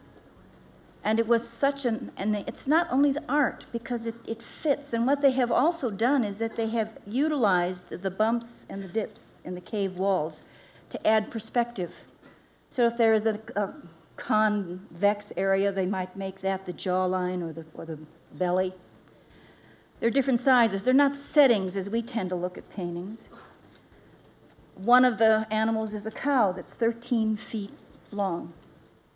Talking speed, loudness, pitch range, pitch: 165 wpm, -27 LUFS, 195-240 Hz, 220 Hz